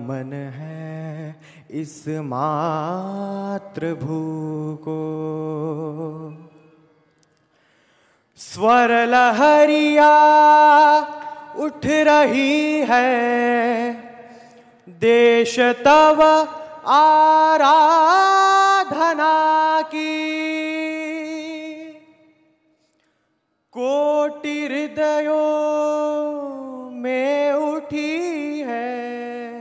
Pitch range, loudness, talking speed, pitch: 195-310 Hz, -17 LUFS, 35 wpm, 285 Hz